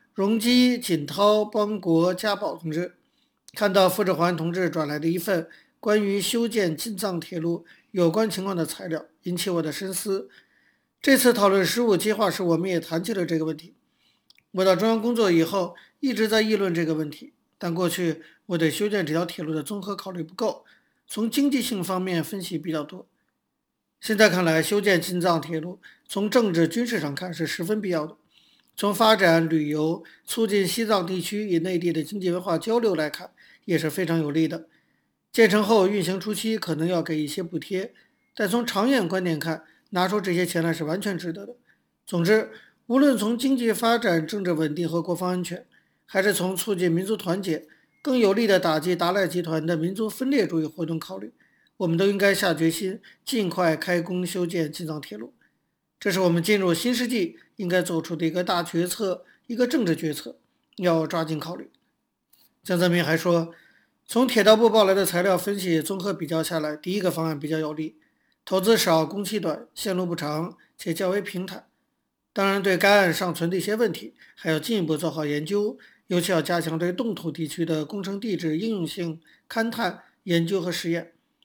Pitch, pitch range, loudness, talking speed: 180 Hz, 165-210 Hz, -24 LUFS, 280 characters per minute